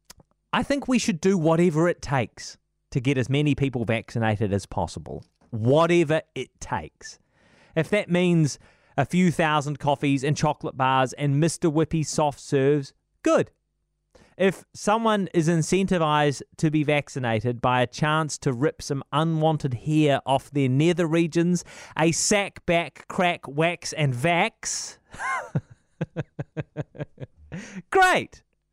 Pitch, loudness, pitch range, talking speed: 155 Hz, -24 LUFS, 140-170 Hz, 130 wpm